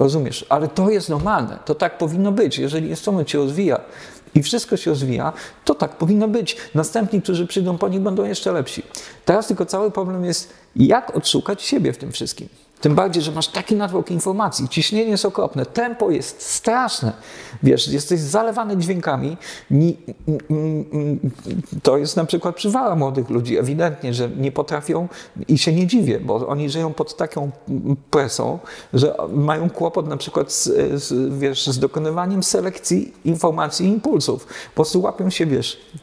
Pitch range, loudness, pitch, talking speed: 150-195 Hz, -20 LUFS, 165 Hz, 170 wpm